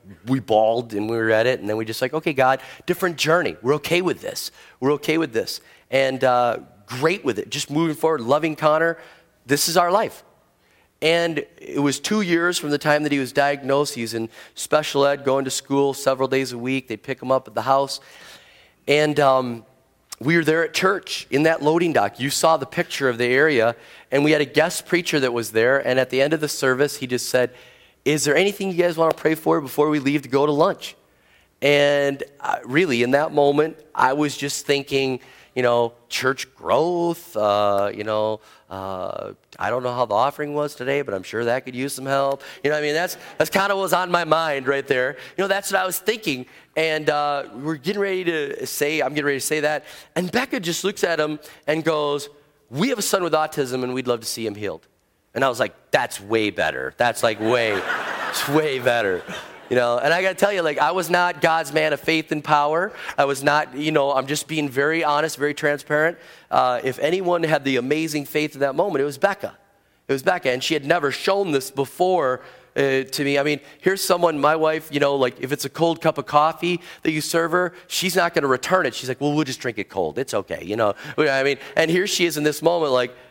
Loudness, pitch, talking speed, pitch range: -21 LUFS, 145 Hz, 235 wpm, 130-160 Hz